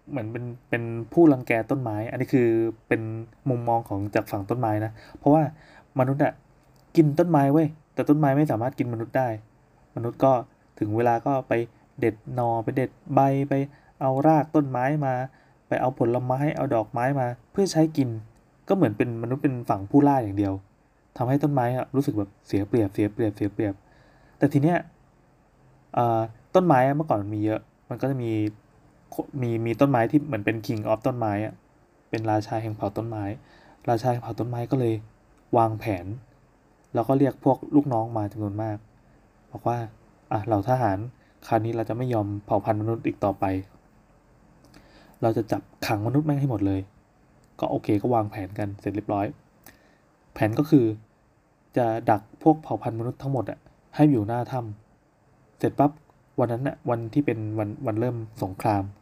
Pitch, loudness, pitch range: 120 Hz, -25 LUFS, 110-140 Hz